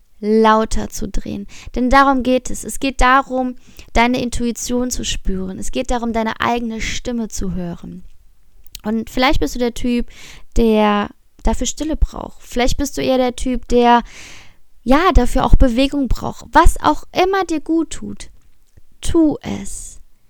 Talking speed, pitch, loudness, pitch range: 155 wpm, 245 Hz, -17 LUFS, 215-260 Hz